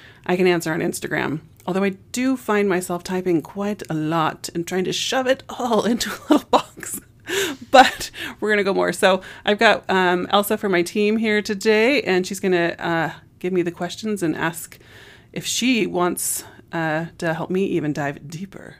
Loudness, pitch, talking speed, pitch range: -21 LUFS, 185 Hz, 195 wpm, 170-215 Hz